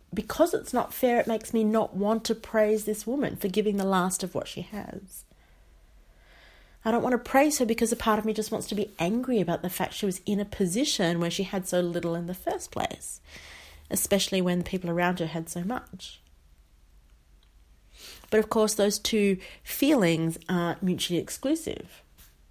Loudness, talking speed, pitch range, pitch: -27 LUFS, 190 wpm, 165-220 Hz, 190 Hz